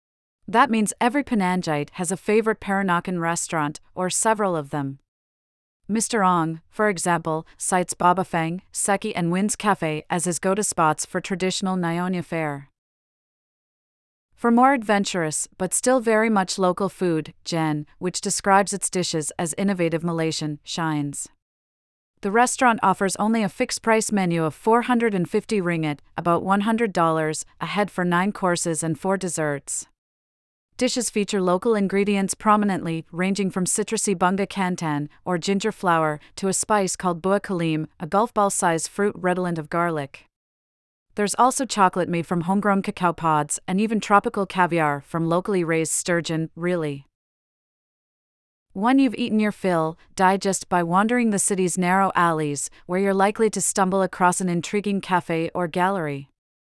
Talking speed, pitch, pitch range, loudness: 145 wpm, 185 Hz, 165-200 Hz, -22 LUFS